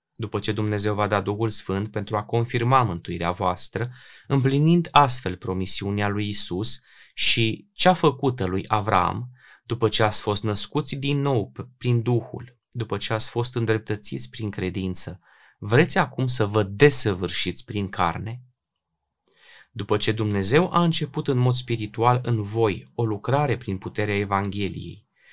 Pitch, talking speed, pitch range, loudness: 110 Hz, 140 wpm, 100-125 Hz, -23 LUFS